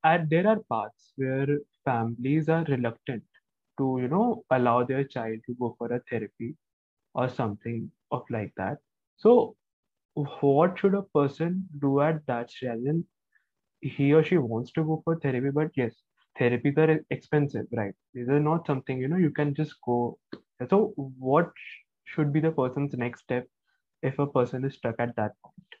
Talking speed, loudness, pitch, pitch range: 170 wpm, -28 LUFS, 135 Hz, 120-155 Hz